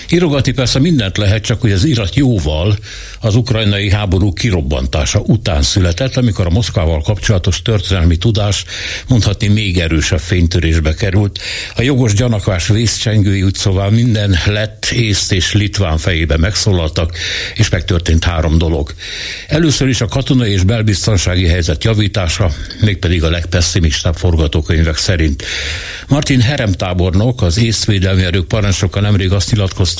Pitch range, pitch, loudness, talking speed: 90-110 Hz, 100 Hz, -13 LUFS, 130 wpm